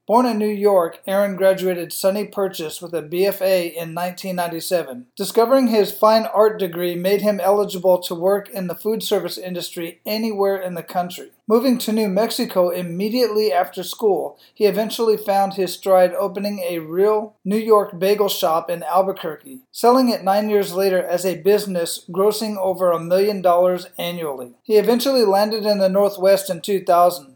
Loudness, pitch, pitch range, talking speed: -19 LUFS, 195 Hz, 180-210 Hz, 165 wpm